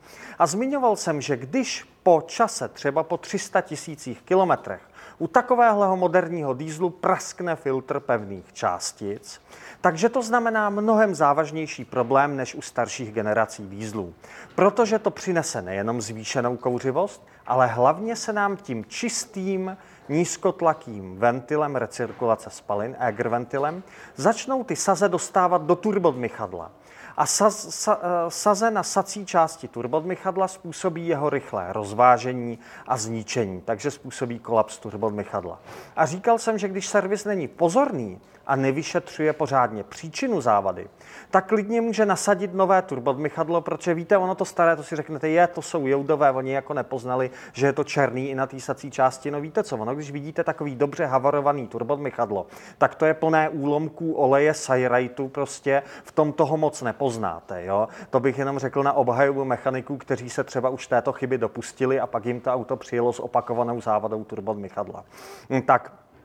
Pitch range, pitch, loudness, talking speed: 125-185 Hz, 145 Hz, -24 LUFS, 150 wpm